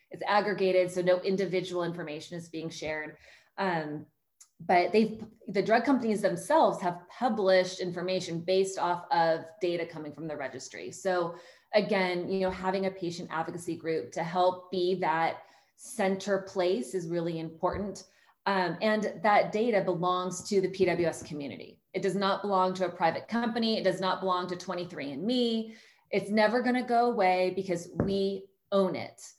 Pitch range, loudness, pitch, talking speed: 175-195 Hz, -29 LUFS, 185 Hz, 160 wpm